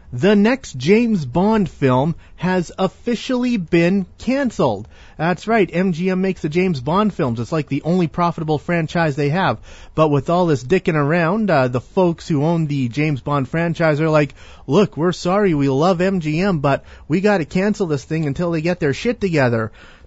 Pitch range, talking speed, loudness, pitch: 145-190 Hz, 190 wpm, -18 LUFS, 170 Hz